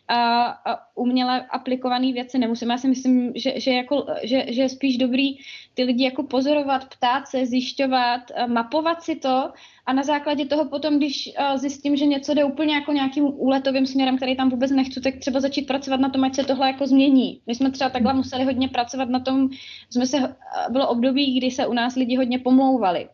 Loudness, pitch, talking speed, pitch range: -22 LUFS, 265 Hz, 195 wpm, 255-275 Hz